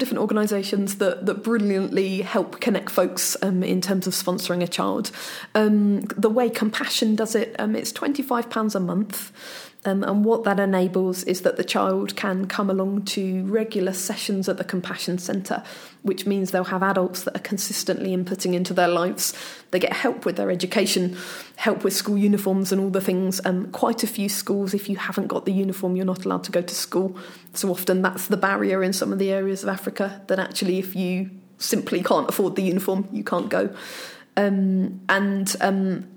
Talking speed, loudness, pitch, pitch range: 195 wpm, -23 LUFS, 195 Hz, 185-205 Hz